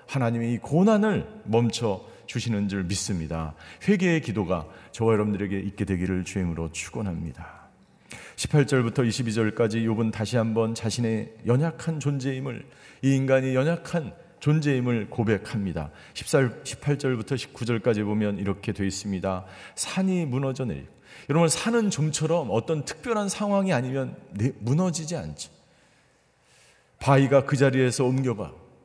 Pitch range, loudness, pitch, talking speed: 105-145 Hz, -26 LUFS, 120 Hz, 300 characters per minute